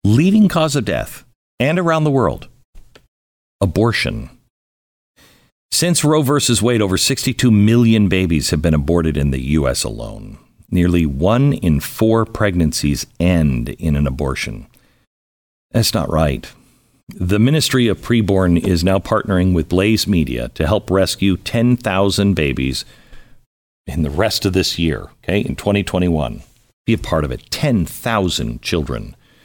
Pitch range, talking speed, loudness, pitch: 75-115 Hz, 135 wpm, -16 LUFS, 95 Hz